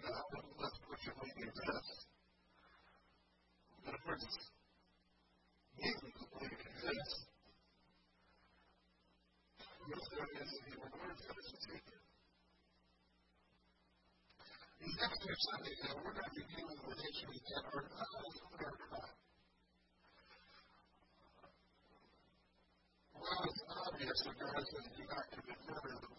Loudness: -47 LUFS